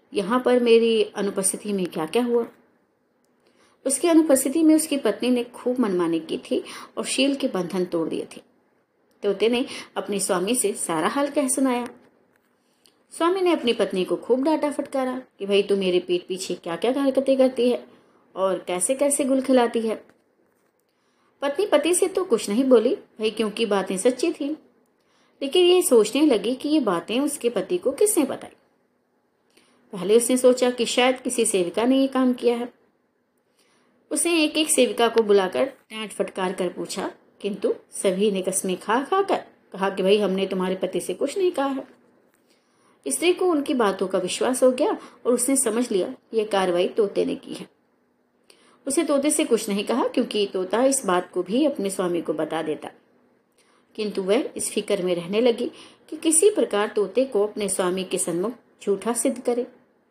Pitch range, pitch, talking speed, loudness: 195-275 Hz, 235 Hz, 175 wpm, -23 LUFS